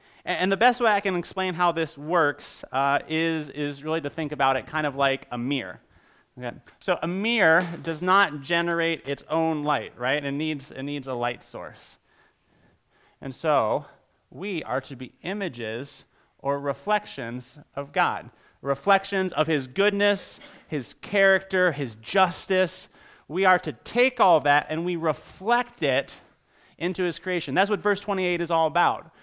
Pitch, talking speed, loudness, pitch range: 160 Hz, 165 wpm, -25 LUFS, 140-185 Hz